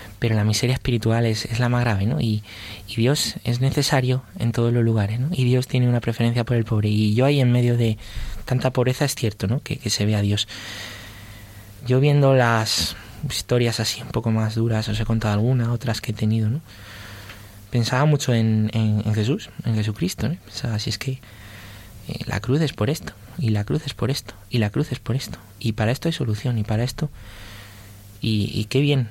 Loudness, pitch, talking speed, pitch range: -22 LUFS, 115 Hz, 220 wpm, 105-125 Hz